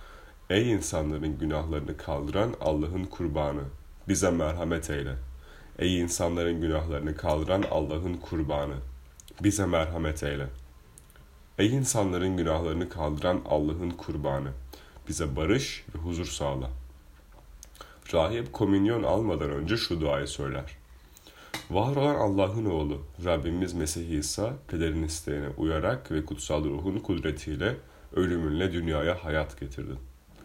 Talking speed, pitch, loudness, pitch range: 105 wpm, 80 Hz, -29 LUFS, 70-90 Hz